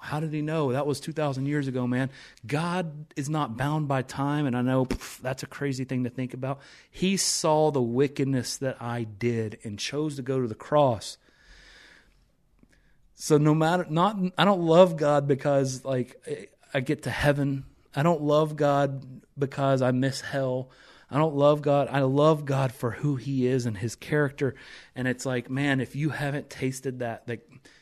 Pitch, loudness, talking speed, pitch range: 140 Hz, -26 LUFS, 190 wpm, 130-150 Hz